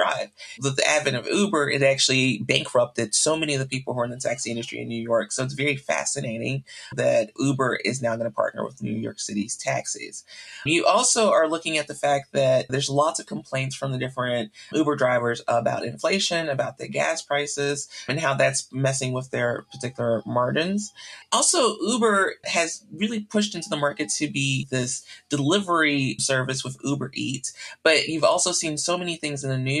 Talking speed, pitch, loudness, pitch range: 195 wpm, 135 Hz, -24 LUFS, 130-160 Hz